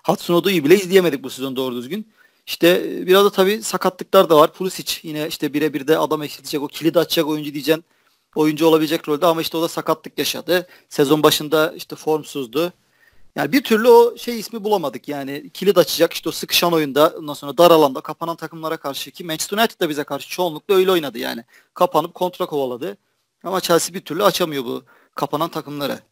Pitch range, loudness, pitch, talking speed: 150-180 Hz, -18 LUFS, 160 Hz, 190 wpm